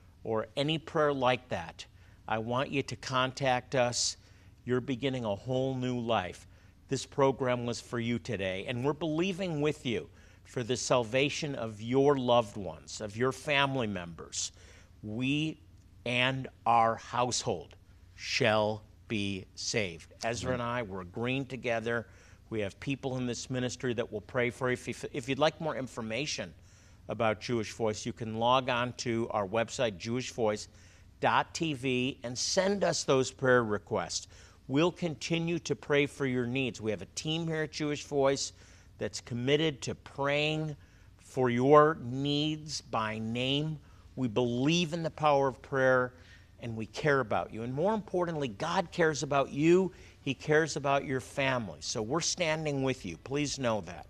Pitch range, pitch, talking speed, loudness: 105-140 Hz, 125 Hz, 155 wpm, -31 LUFS